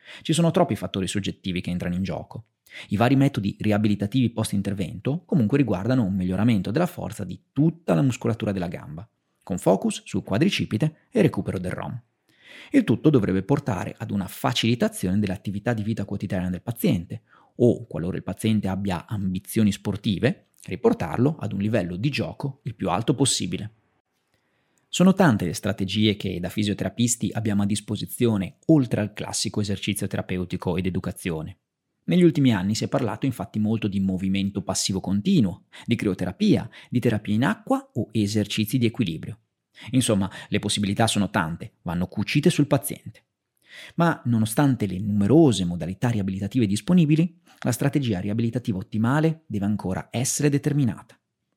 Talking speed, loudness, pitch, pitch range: 150 wpm, -24 LUFS, 105 Hz, 95-130 Hz